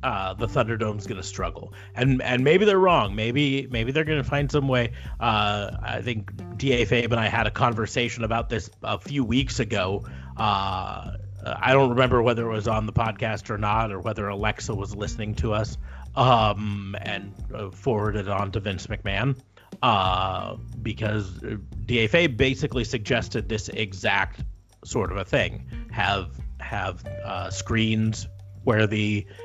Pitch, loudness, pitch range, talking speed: 110 Hz, -25 LUFS, 100-120 Hz, 160 wpm